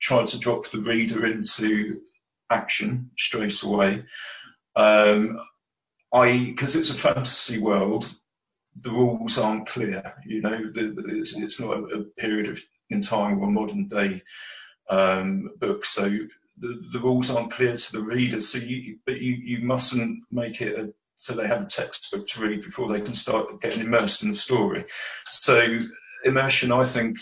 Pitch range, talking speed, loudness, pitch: 105-125 Hz, 155 wpm, -24 LUFS, 115 Hz